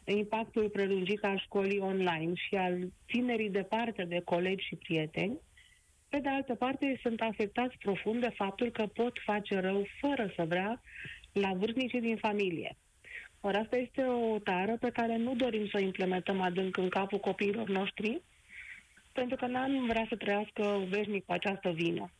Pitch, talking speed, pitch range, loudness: 205 Hz, 160 wpm, 190-235 Hz, -34 LUFS